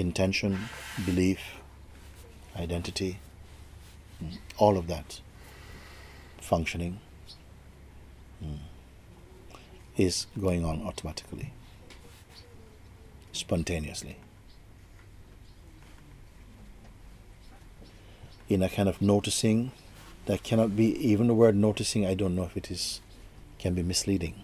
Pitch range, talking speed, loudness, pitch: 85-100 Hz, 85 wpm, -29 LUFS, 95 Hz